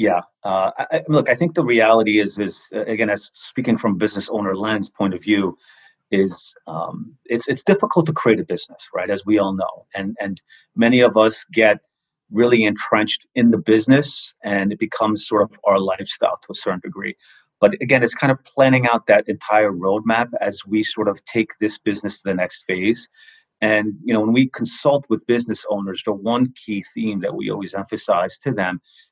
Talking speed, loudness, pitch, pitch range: 200 wpm, -19 LUFS, 110 Hz, 100-120 Hz